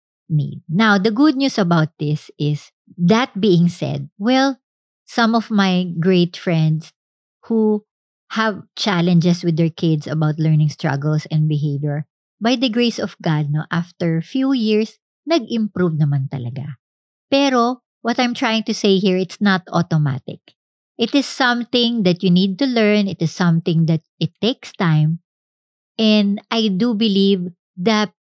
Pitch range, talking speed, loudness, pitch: 160-225 Hz, 155 wpm, -18 LUFS, 190 Hz